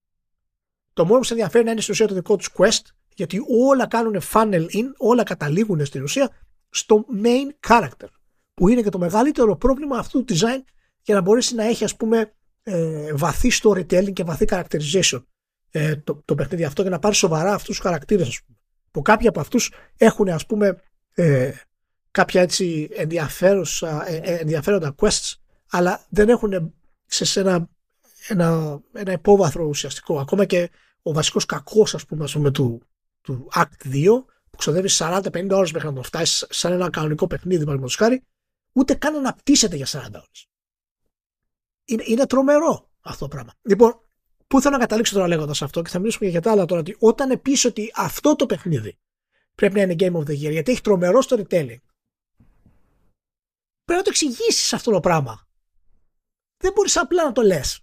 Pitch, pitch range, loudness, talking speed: 190 Hz, 160-225 Hz, -20 LUFS, 170 wpm